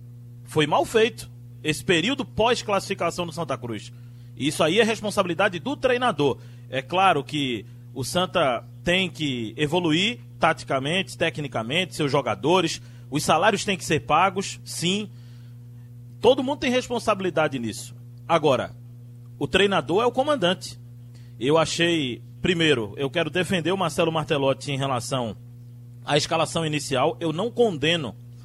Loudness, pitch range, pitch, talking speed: -23 LUFS, 120-180 Hz, 150 Hz, 135 wpm